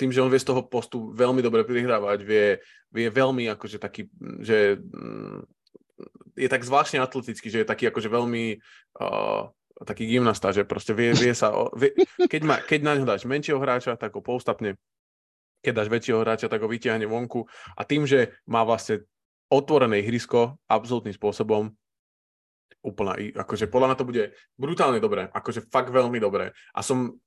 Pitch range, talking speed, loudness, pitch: 110-130 Hz, 165 wpm, -24 LUFS, 120 Hz